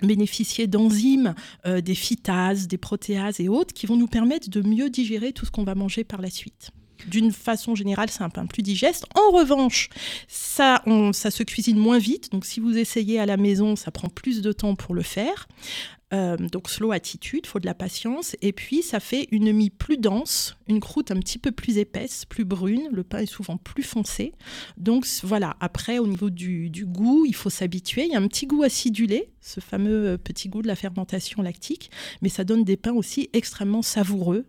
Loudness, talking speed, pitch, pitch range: -24 LUFS, 210 wpm, 215 Hz, 195-235 Hz